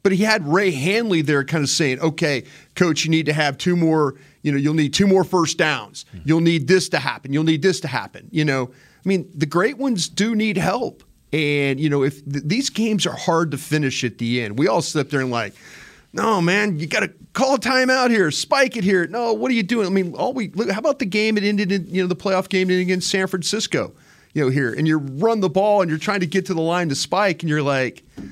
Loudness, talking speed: -20 LUFS, 260 wpm